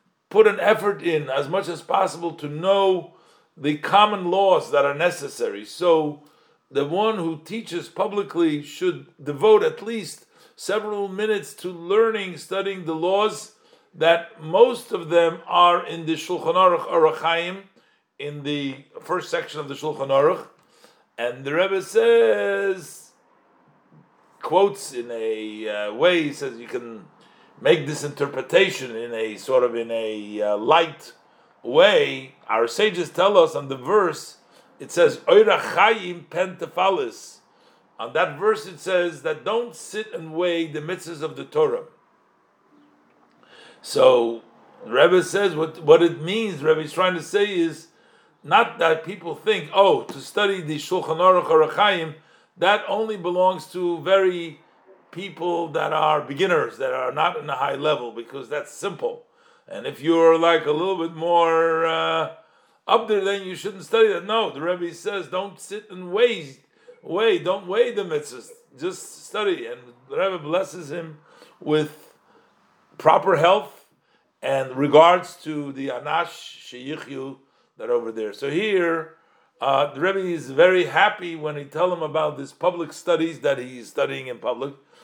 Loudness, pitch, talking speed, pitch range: -21 LUFS, 175 Hz, 150 wpm, 155-205 Hz